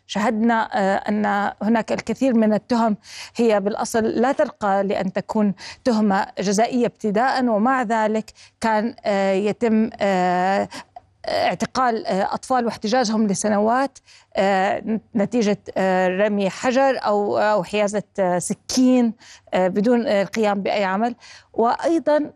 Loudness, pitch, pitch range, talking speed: -20 LUFS, 215 Hz, 200-240 Hz, 90 wpm